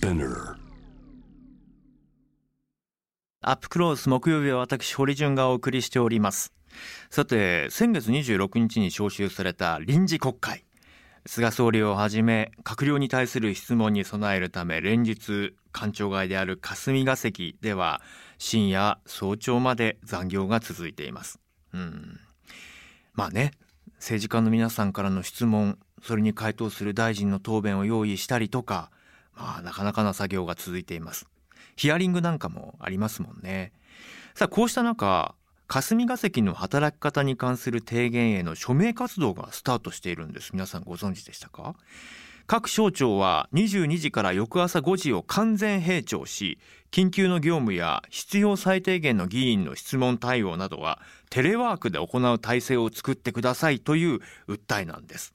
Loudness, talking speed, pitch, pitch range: -26 LUFS, 290 characters per minute, 120 Hz, 100-150 Hz